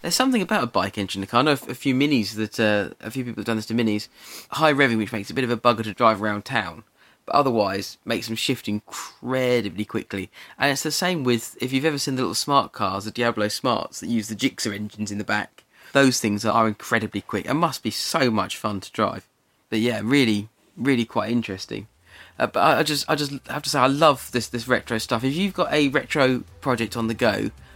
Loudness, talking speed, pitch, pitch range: -23 LUFS, 235 wpm, 115 Hz, 105-135 Hz